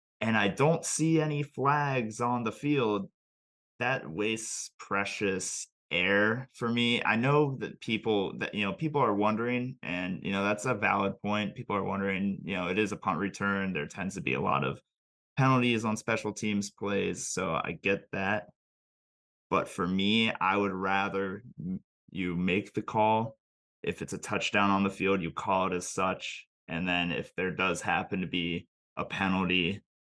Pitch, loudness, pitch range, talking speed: 100 Hz, -30 LUFS, 95-120 Hz, 180 wpm